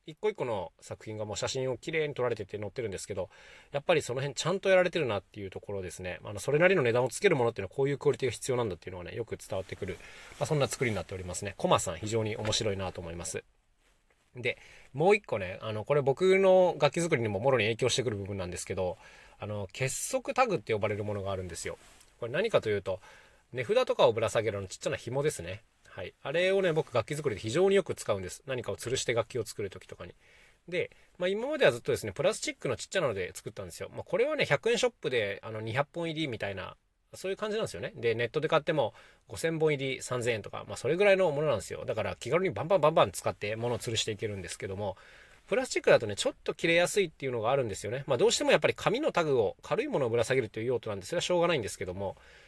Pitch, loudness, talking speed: 145 Hz, -30 LUFS, 540 characters per minute